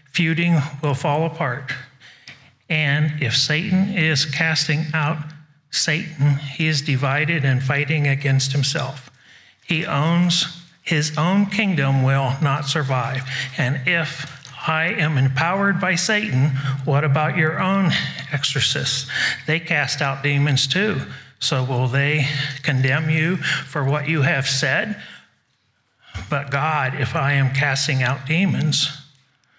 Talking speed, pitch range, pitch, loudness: 125 wpm, 135-160 Hz, 145 Hz, -20 LUFS